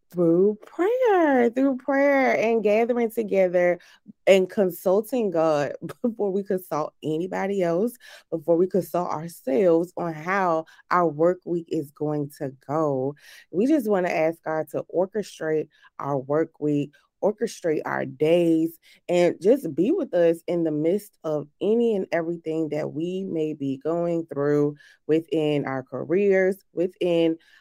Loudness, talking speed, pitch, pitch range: -24 LUFS, 140 wpm, 170 Hz, 155-200 Hz